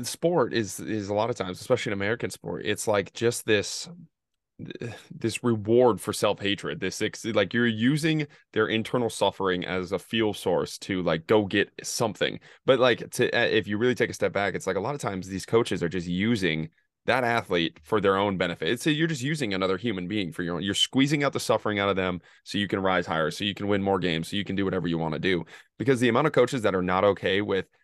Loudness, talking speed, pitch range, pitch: -26 LUFS, 235 wpm, 95-120 Hz, 105 Hz